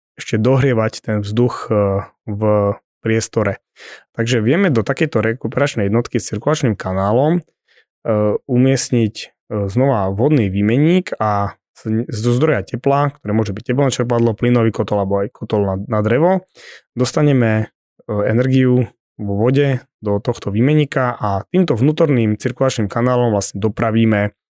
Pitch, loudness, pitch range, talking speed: 115 Hz, -17 LUFS, 105-130 Hz, 120 wpm